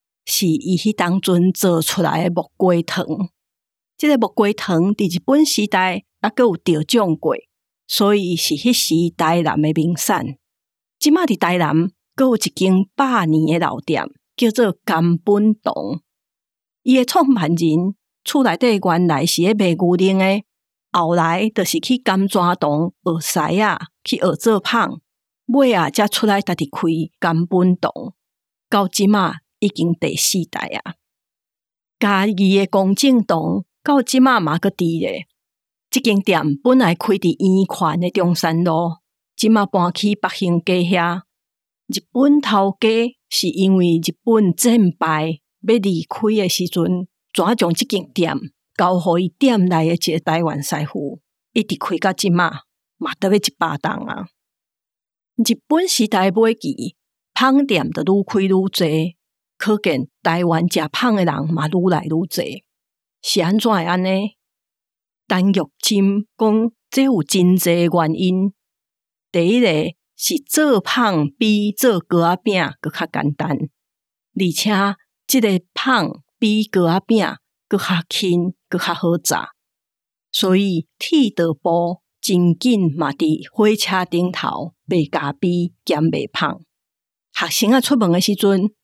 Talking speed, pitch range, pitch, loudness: 190 characters per minute, 170-215 Hz, 185 Hz, -17 LUFS